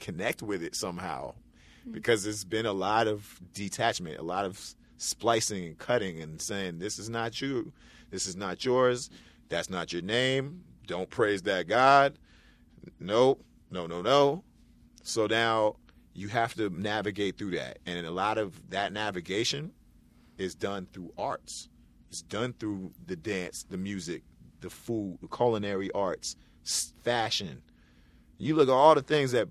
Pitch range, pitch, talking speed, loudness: 90-115 Hz, 100 Hz, 155 wpm, -30 LUFS